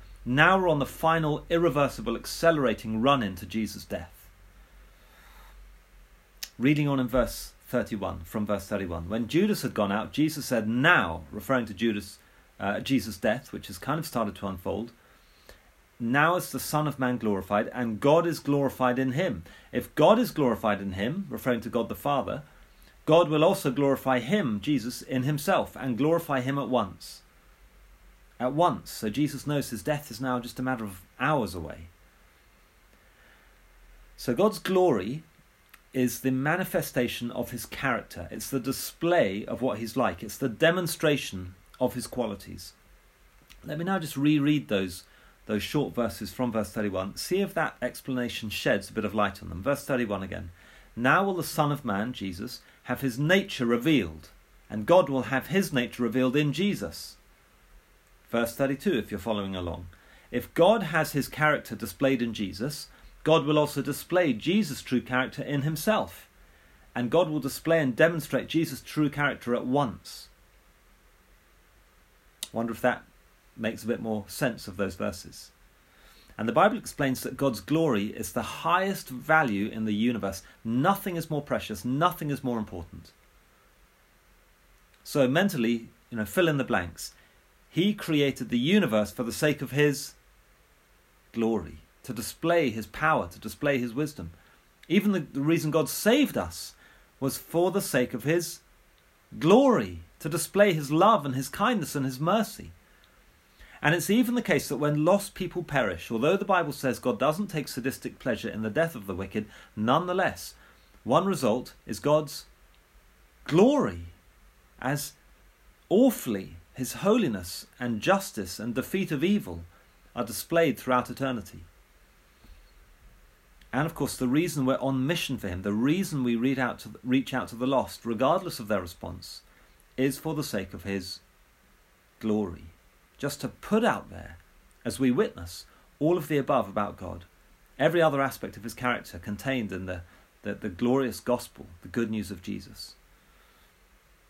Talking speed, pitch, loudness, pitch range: 160 wpm, 125 Hz, -27 LUFS, 95-150 Hz